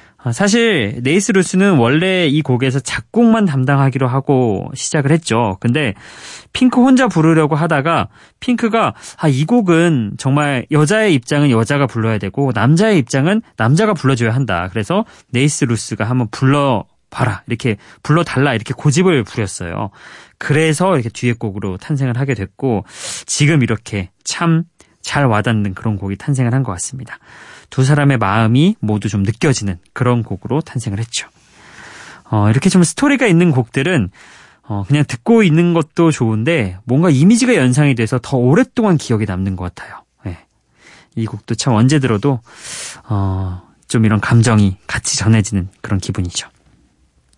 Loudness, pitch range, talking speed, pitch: -15 LUFS, 110-160 Hz, 325 characters per minute, 130 Hz